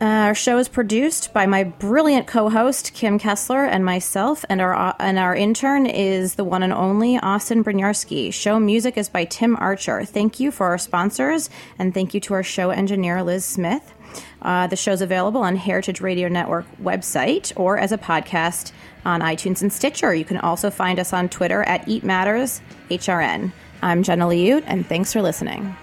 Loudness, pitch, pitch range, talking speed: -20 LUFS, 195 Hz, 185-220 Hz, 185 wpm